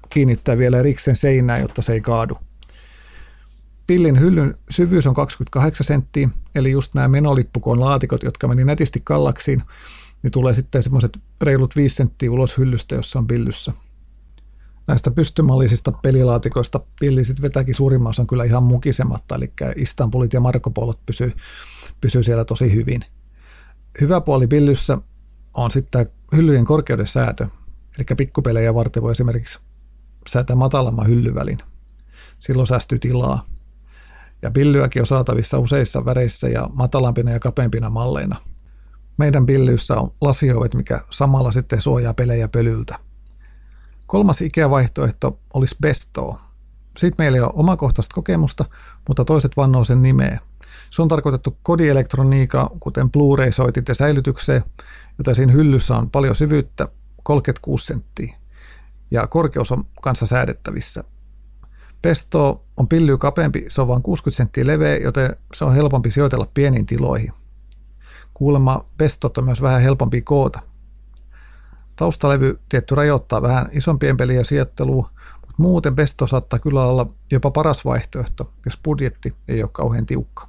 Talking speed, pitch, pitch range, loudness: 135 wpm, 130 Hz, 115-140 Hz, -17 LUFS